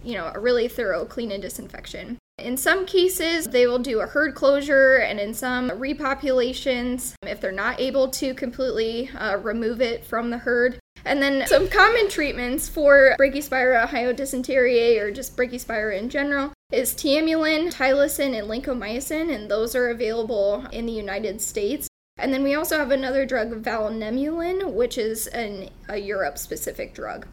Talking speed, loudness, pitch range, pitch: 165 wpm, -22 LUFS, 230-280 Hz, 255 Hz